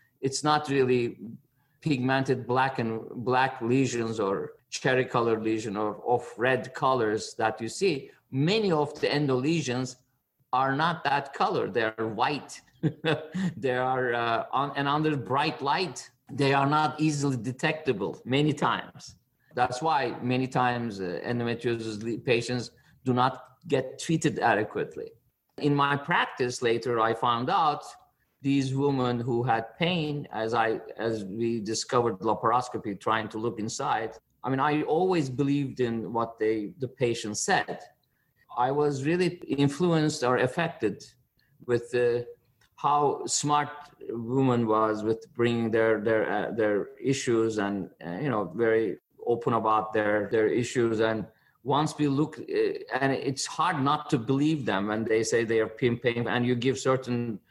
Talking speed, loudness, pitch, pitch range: 150 wpm, -27 LUFS, 125 Hz, 115-145 Hz